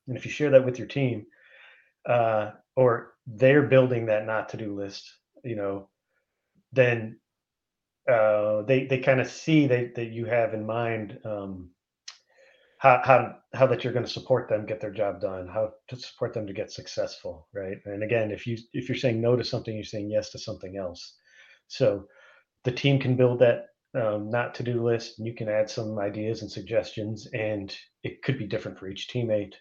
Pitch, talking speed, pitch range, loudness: 115 Hz, 195 wpm, 105-125 Hz, -26 LUFS